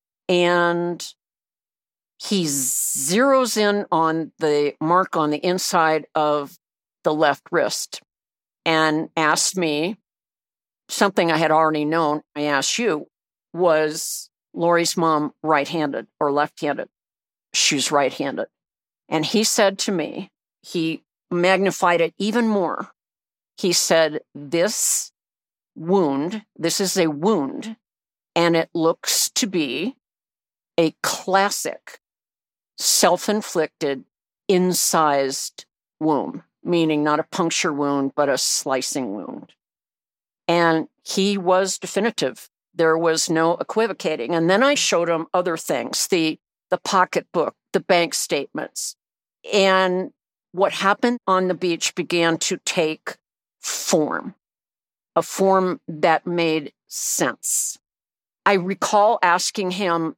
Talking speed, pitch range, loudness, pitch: 115 wpm, 160-195 Hz, -20 LUFS, 170 Hz